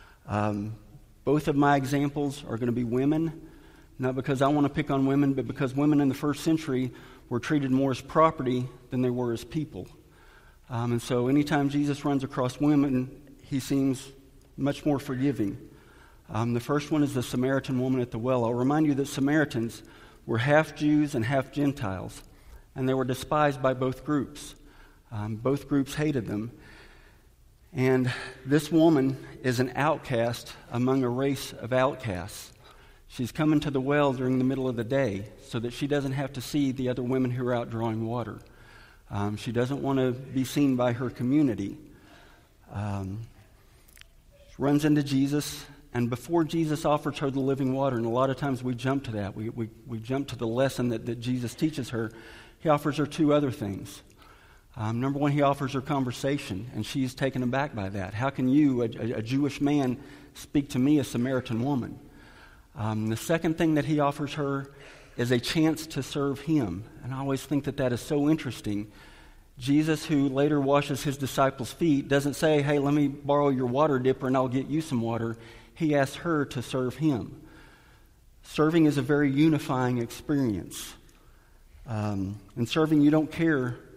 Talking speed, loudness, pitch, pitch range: 185 wpm, -27 LUFS, 135 Hz, 120-145 Hz